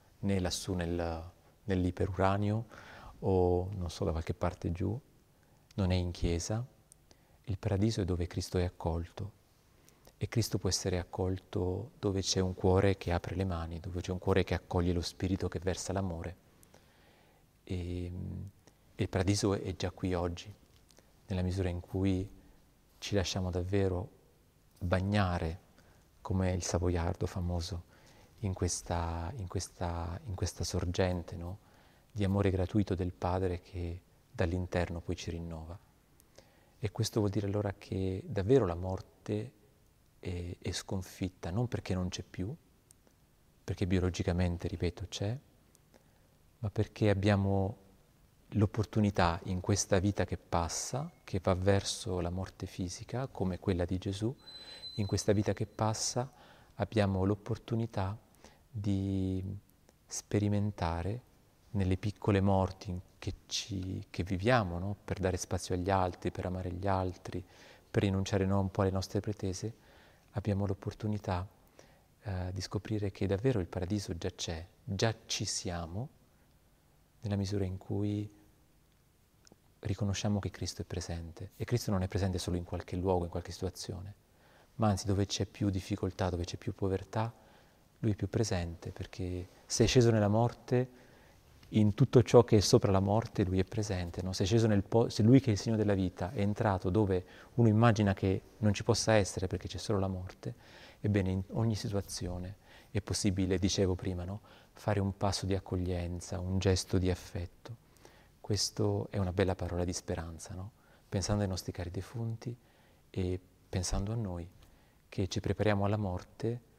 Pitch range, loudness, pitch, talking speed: 90-105 Hz, -34 LUFS, 95 Hz, 150 wpm